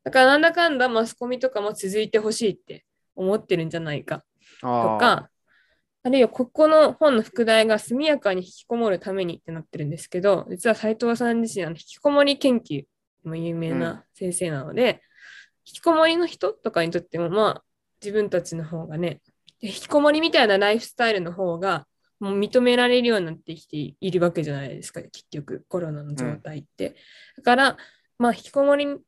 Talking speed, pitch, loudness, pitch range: 380 characters per minute, 205 Hz, -22 LUFS, 170-245 Hz